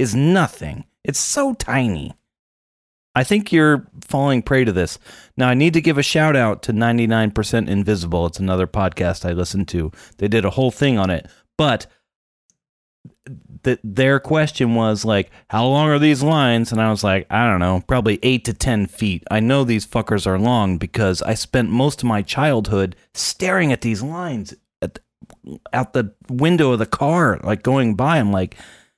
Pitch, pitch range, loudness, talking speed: 115 Hz, 100-135 Hz, -18 LUFS, 185 wpm